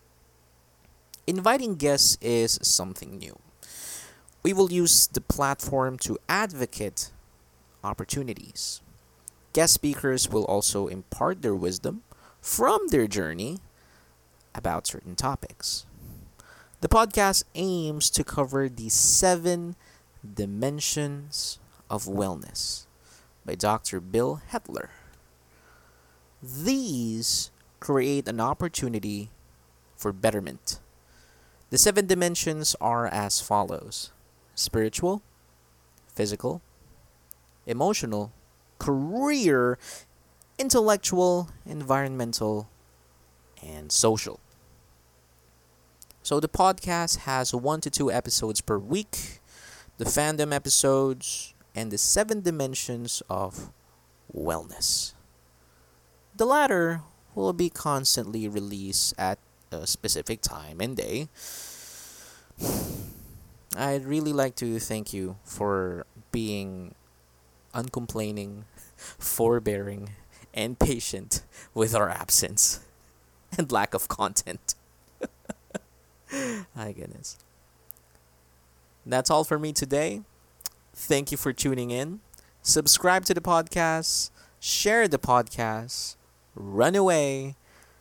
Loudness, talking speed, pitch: -26 LUFS, 90 wpm, 110 Hz